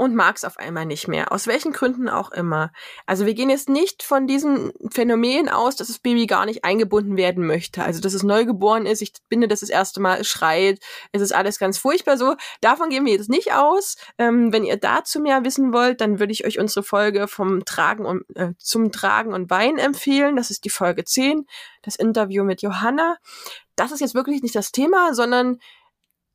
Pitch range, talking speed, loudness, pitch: 200-270 Hz, 210 wpm, -20 LUFS, 225 Hz